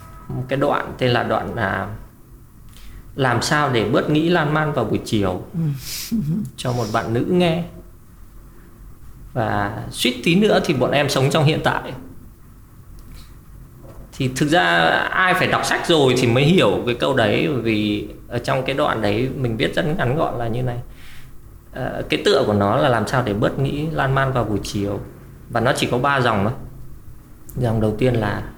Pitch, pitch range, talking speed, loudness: 120 Hz, 110-135 Hz, 185 wpm, -19 LUFS